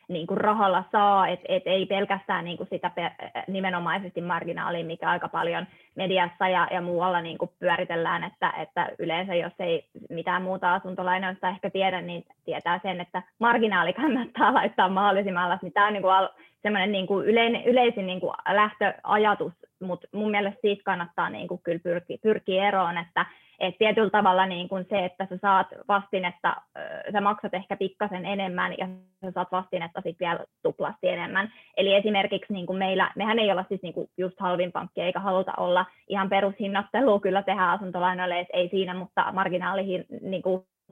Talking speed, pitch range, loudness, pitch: 155 wpm, 180-200 Hz, -26 LUFS, 190 Hz